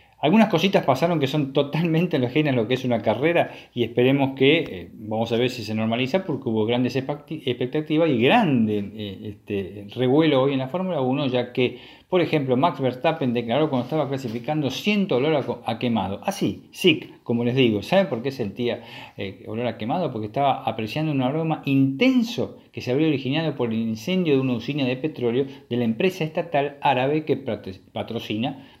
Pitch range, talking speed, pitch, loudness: 115-155 Hz, 185 wpm, 130 Hz, -23 LUFS